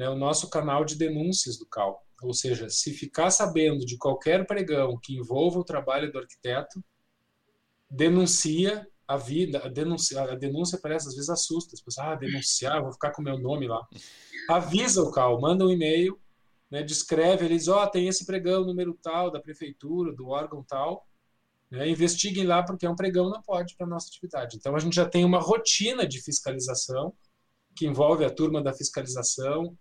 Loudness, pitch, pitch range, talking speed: -26 LUFS, 155 Hz, 135-175 Hz, 180 wpm